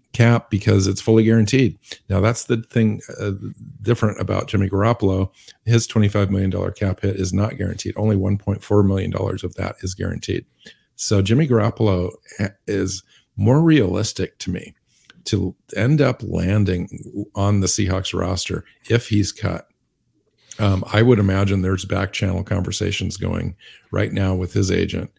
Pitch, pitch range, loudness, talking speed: 105 Hz, 95-110 Hz, -20 LUFS, 160 wpm